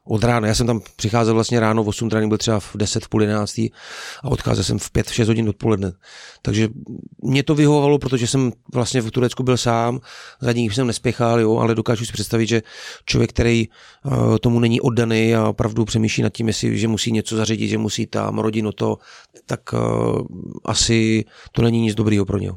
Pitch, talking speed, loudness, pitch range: 115 Hz, 205 wpm, -19 LUFS, 110-120 Hz